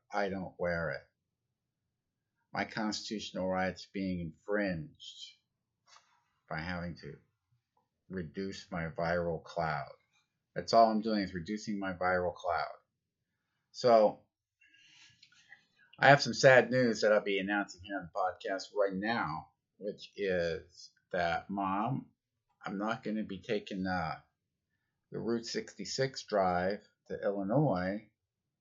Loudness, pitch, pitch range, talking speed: -33 LUFS, 100 Hz, 95-115 Hz, 120 wpm